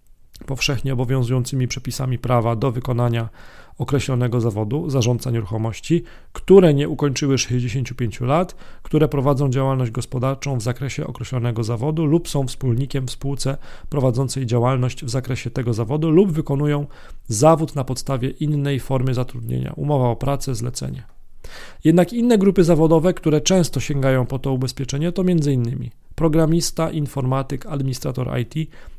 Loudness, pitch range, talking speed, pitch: -20 LUFS, 125-150 Hz, 130 wpm, 135 Hz